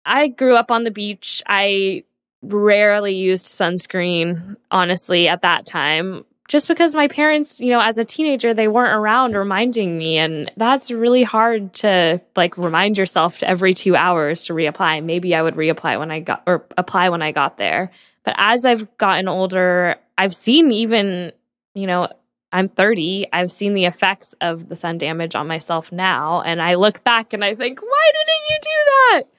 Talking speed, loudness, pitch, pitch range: 185 wpm, -17 LUFS, 190 Hz, 175-230 Hz